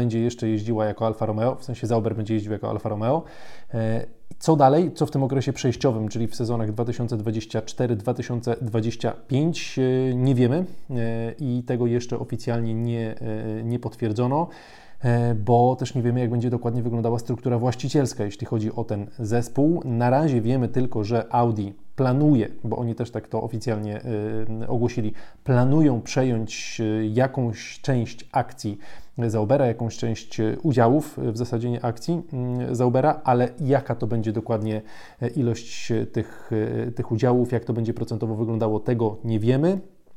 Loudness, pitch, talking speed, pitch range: -24 LUFS, 120 Hz, 140 wpm, 115-125 Hz